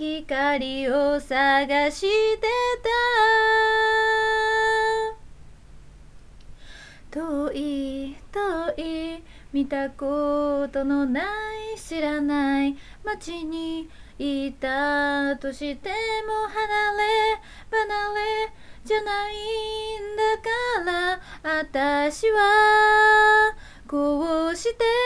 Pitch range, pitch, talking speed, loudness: 285-435 Hz, 370 Hz, 115 characters per minute, -23 LUFS